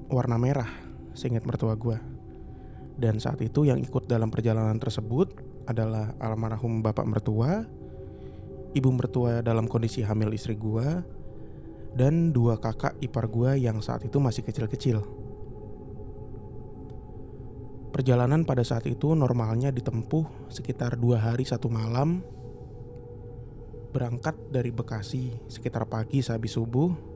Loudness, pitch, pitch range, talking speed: -28 LUFS, 120 Hz, 110-130 Hz, 115 wpm